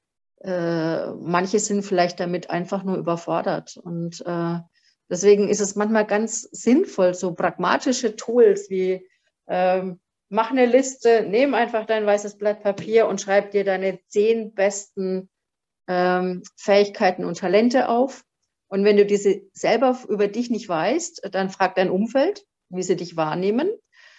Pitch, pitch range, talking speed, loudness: 200 Hz, 185-220 Hz, 135 wpm, -22 LUFS